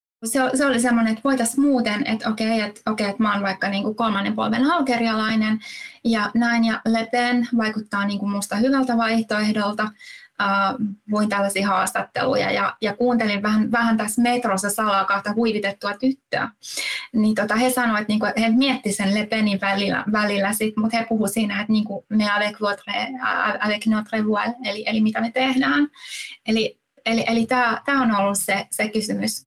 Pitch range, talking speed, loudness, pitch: 205-240 Hz, 175 wpm, -21 LUFS, 220 Hz